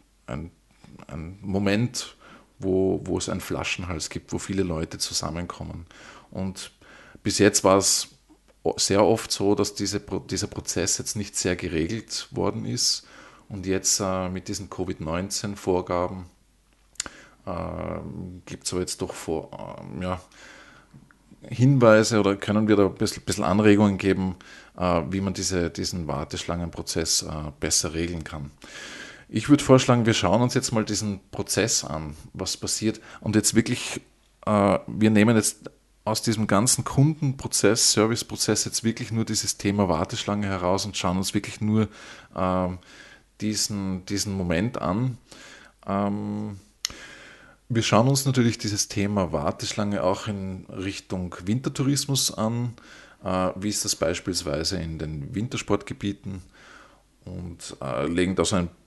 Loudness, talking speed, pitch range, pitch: -24 LUFS, 130 wpm, 90-110 Hz, 100 Hz